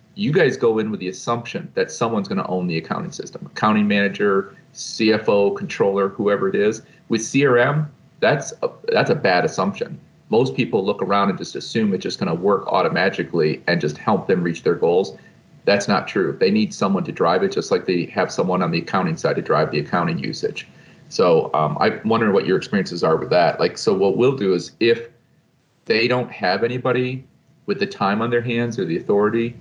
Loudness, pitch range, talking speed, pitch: -20 LUFS, 105-170 Hz, 205 wpm, 120 Hz